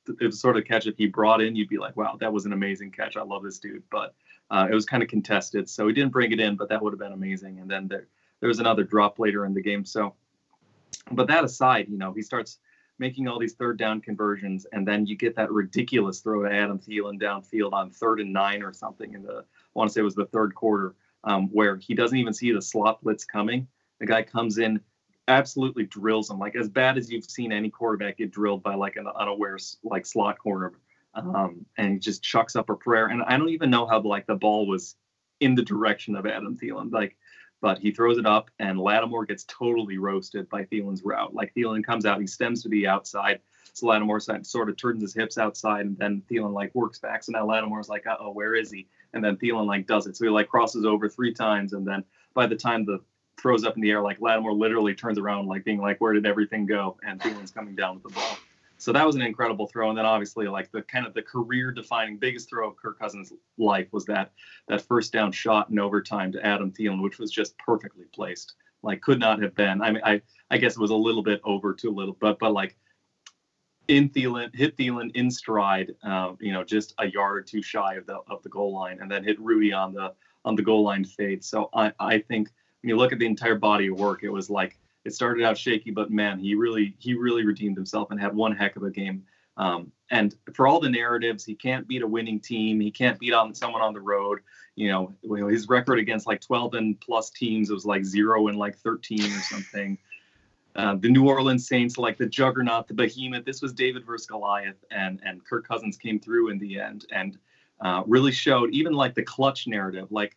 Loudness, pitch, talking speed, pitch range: -25 LUFS, 105 Hz, 240 wpm, 100-115 Hz